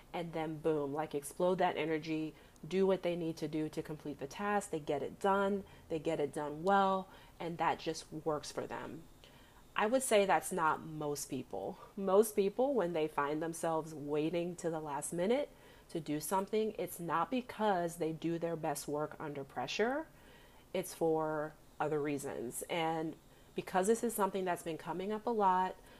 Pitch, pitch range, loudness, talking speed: 165 Hz, 155-190 Hz, -36 LUFS, 180 wpm